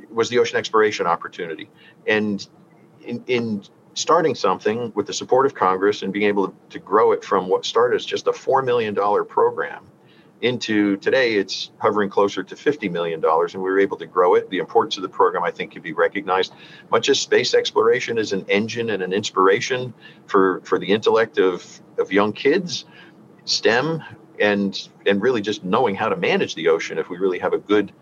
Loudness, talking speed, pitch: -20 LUFS, 195 wpm, 150 Hz